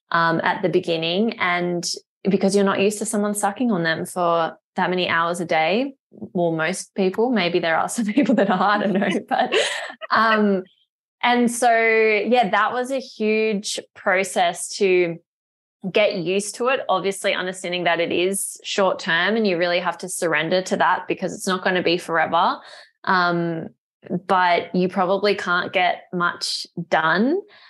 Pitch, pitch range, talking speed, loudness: 190 Hz, 175-215 Hz, 170 wpm, -21 LUFS